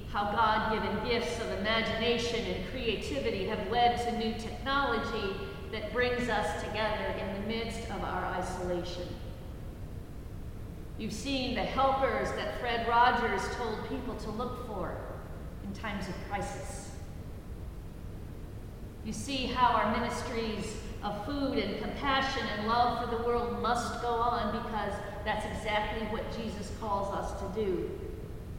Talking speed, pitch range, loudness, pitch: 135 wpm, 205-240 Hz, -32 LUFS, 225 Hz